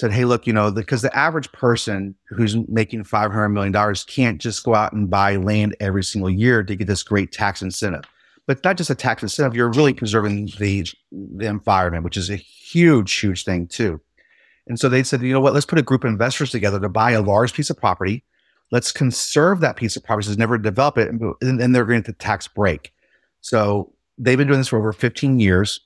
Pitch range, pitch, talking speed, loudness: 100-130 Hz, 110 Hz, 230 wpm, -19 LUFS